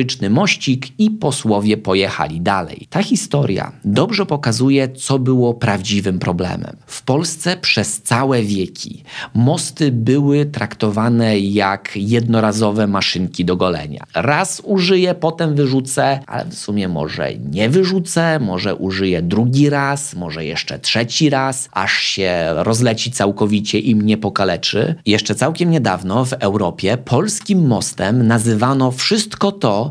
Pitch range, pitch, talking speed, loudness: 105-145 Hz, 120 Hz, 120 wpm, -16 LUFS